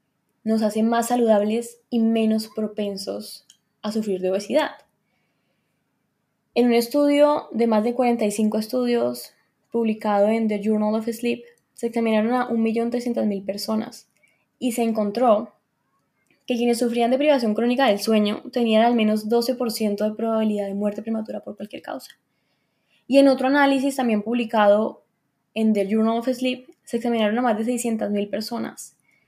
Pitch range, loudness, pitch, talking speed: 215-240 Hz, -22 LUFS, 225 Hz, 145 wpm